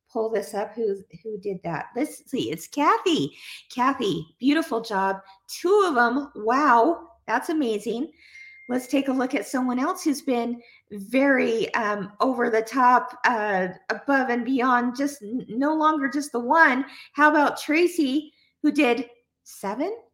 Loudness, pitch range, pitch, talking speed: -23 LUFS, 225-295 Hz, 250 Hz, 150 wpm